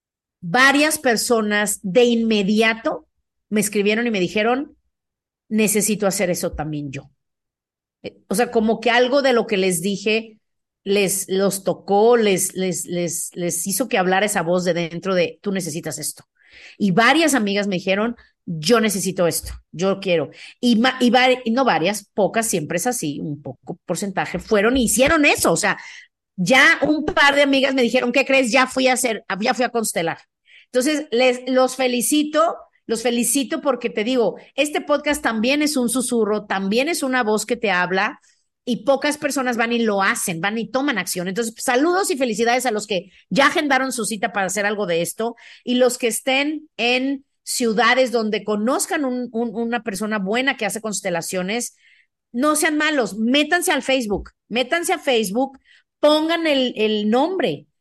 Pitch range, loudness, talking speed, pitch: 195-265 Hz, -19 LUFS, 175 wpm, 235 Hz